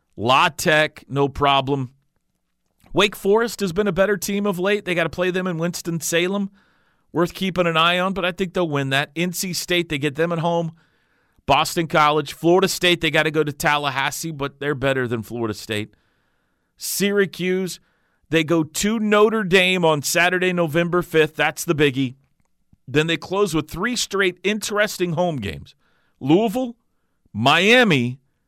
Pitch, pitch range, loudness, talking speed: 170 Hz, 150-190 Hz, -20 LUFS, 165 wpm